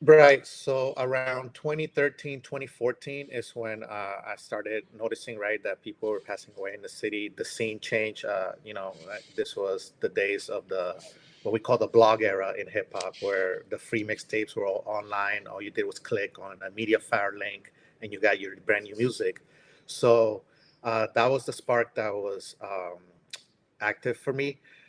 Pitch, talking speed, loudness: 140 Hz, 185 wpm, -29 LUFS